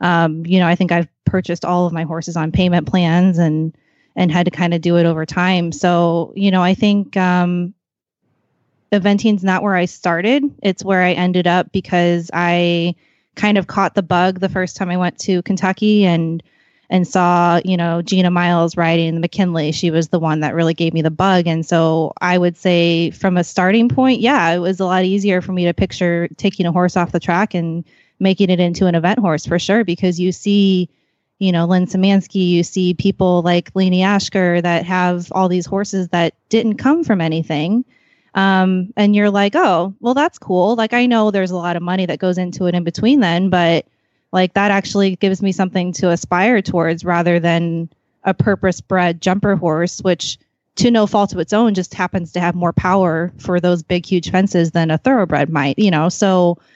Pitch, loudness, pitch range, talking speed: 180 Hz, -16 LUFS, 170-195 Hz, 205 wpm